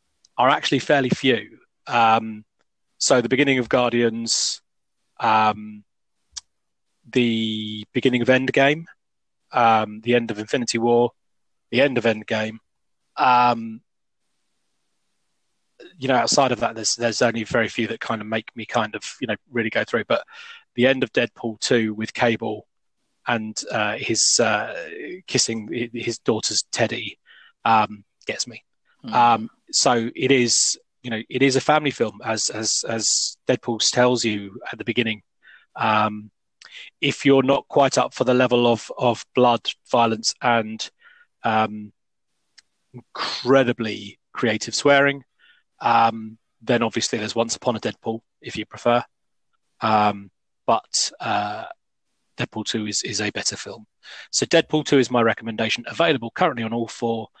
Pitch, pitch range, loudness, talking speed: 115 Hz, 110-125 Hz, -21 LUFS, 145 wpm